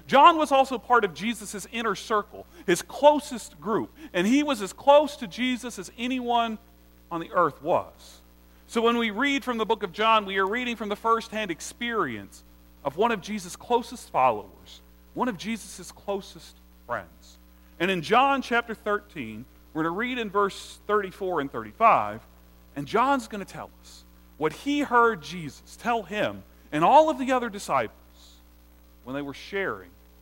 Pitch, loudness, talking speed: 205 Hz, -25 LUFS, 175 wpm